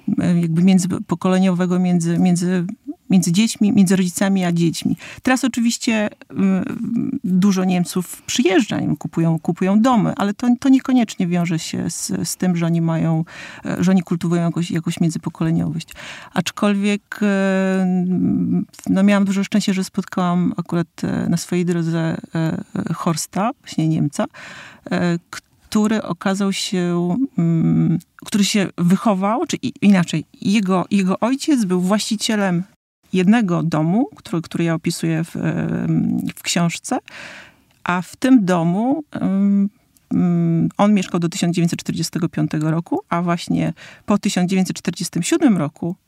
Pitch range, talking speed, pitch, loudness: 170-210 Hz, 110 wpm, 185 Hz, -19 LUFS